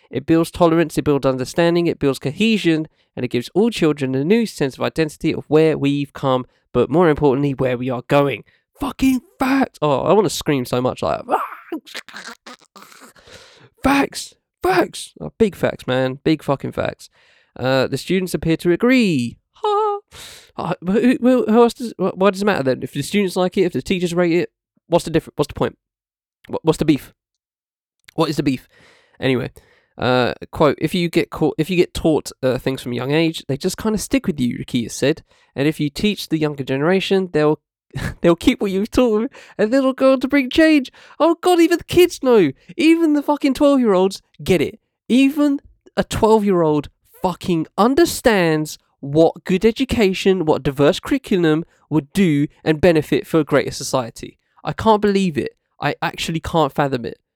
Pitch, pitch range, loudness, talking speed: 170 Hz, 145-220 Hz, -18 LUFS, 185 wpm